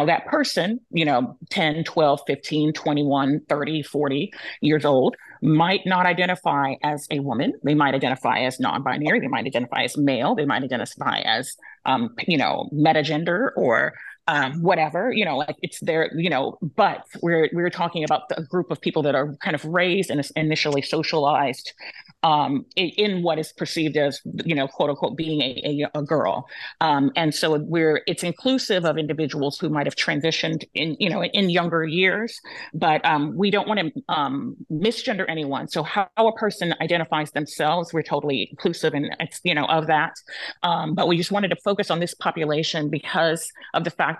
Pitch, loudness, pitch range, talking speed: 160 Hz, -22 LUFS, 150-180 Hz, 185 wpm